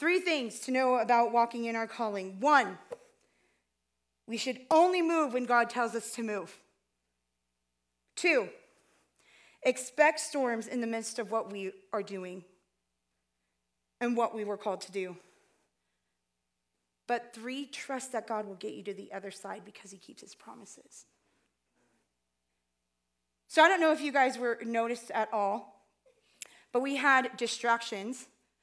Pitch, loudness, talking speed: 220 Hz, -30 LUFS, 145 wpm